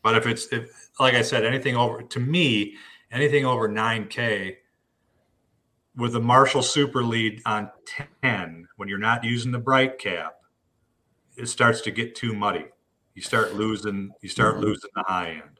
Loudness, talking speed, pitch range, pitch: -23 LUFS, 165 wpm, 105-125 Hz, 115 Hz